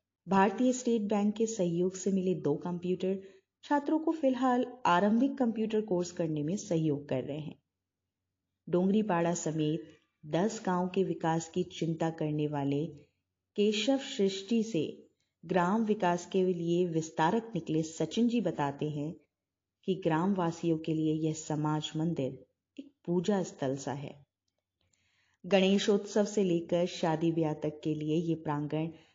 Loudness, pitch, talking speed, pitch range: -31 LUFS, 170 Hz, 135 wpm, 150-195 Hz